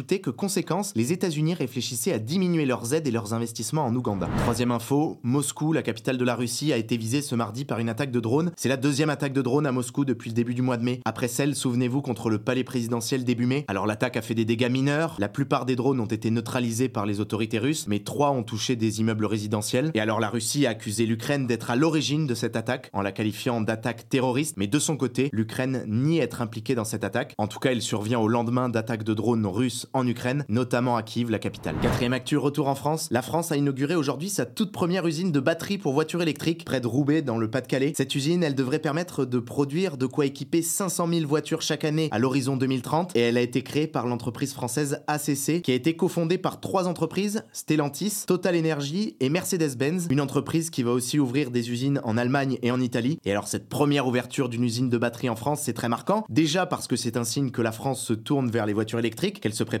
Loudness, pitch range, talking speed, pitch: -26 LUFS, 120-150 Hz, 240 wpm, 130 Hz